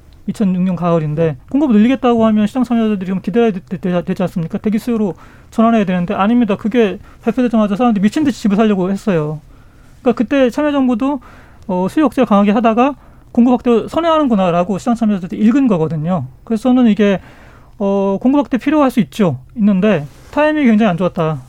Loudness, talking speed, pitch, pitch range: -14 LUFS, 415 characters per minute, 215 Hz, 185-245 Hz